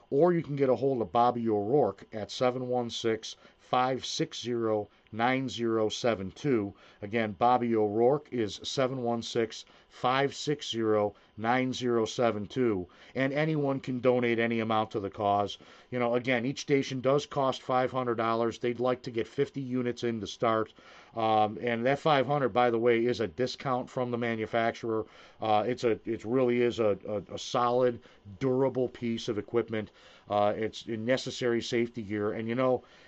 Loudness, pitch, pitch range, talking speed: -30 LUFS, 120 Hz, 110-130 Hz, 145 wpm